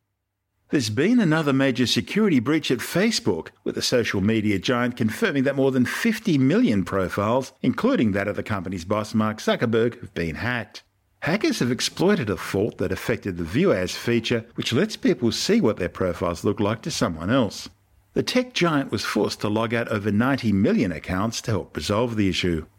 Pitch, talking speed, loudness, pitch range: 115 Hz, 185 wpm, -23 LUFS, 100-135 Hz